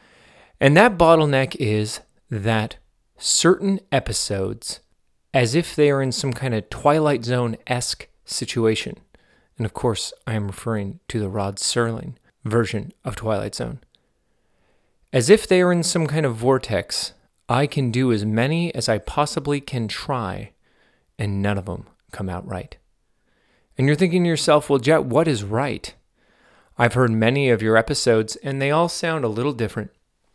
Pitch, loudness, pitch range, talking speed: 125 Hz, -21 LUFS, 110-145 Hz, 160 wpm